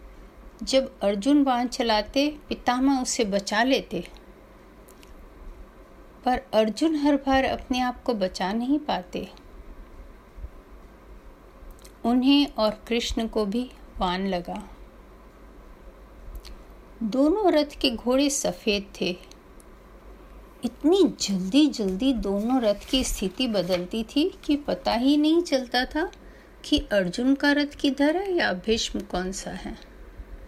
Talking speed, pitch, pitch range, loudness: 110 wpm, 250 Hz, 205-285 Hz, -24 LUFS